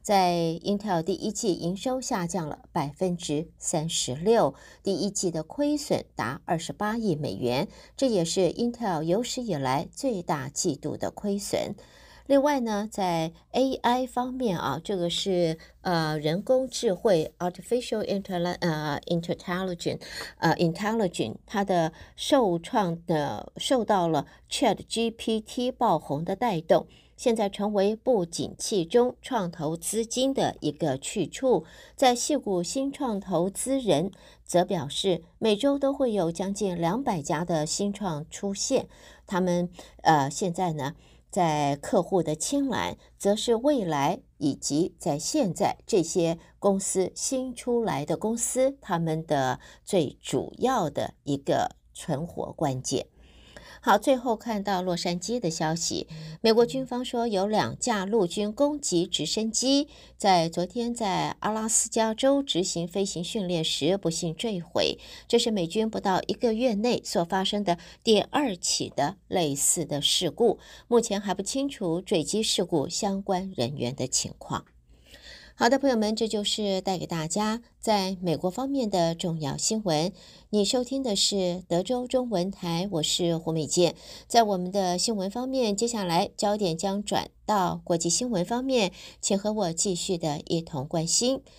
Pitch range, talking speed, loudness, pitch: 170-230 Hz, 240 characters per minute, -27 LUFS, 195 Hz